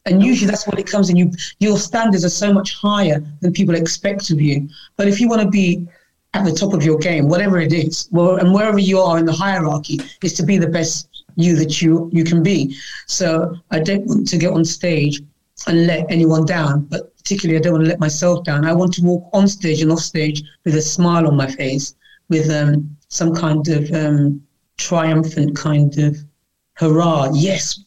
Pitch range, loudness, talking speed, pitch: 155-185 Hz, -16 LUFS, 215 wpm, 165 Hz